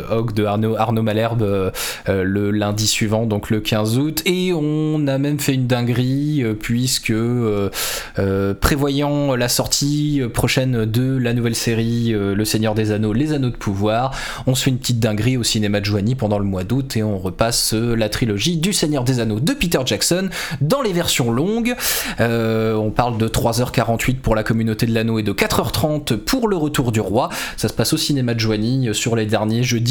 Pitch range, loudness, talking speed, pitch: 110-135 Hz, -19 LUFS, 200 wpm, 115 Hz